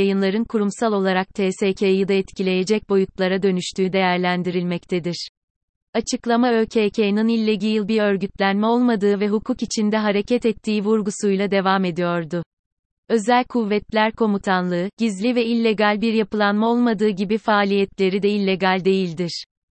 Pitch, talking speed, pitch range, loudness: 205 Hz, 115 wpm, 190-220 Hz, -20 LUFS